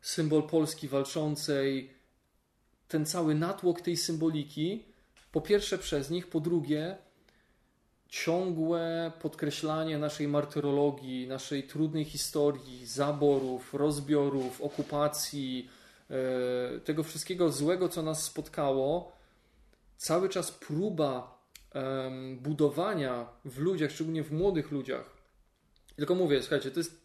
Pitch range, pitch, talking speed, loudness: 140-165 Hz, 150 Hz, 100 wpm, -32 LUFS